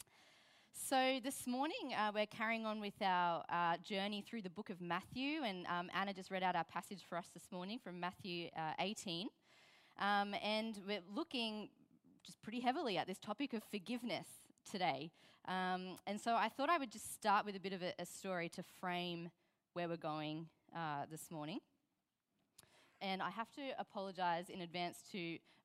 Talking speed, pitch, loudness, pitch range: 180 wpm, 195 Hz, -43 LUFS, 175-220 Hz